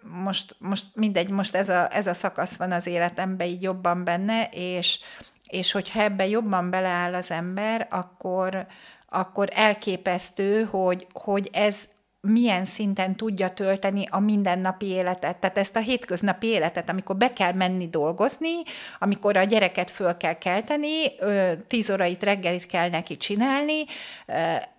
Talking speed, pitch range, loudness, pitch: 140 wpm, 180-210 Hz, -25 LUFS, 190 Hz